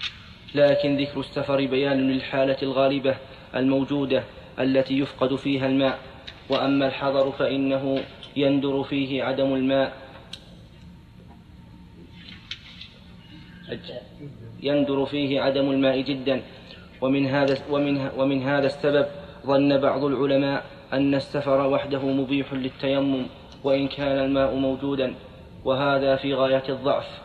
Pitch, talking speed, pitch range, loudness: 135 Hz, 100 wpm, 135-140 Hz, -24 LUFS